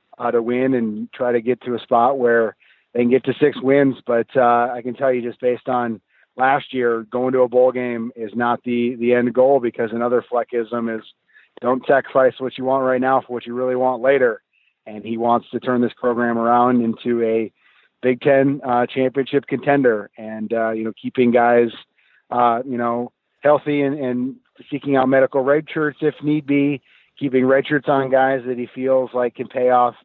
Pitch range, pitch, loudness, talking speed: 120-130 Hz, 125 Hz, -19 LUFS, 205 wpm